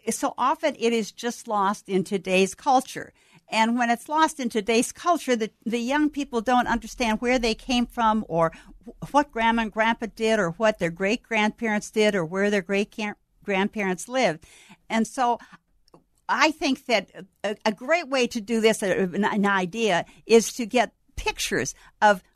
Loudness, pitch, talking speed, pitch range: -24 LUFS, 225 Hz, 170 wpm, 205-245 Hz